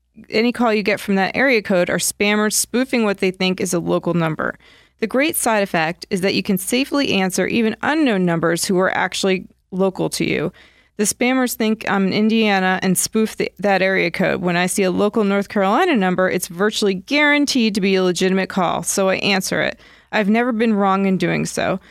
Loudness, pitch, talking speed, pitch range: -18 LUFS, 200 Hz, 210 wpm, 185-225 Hz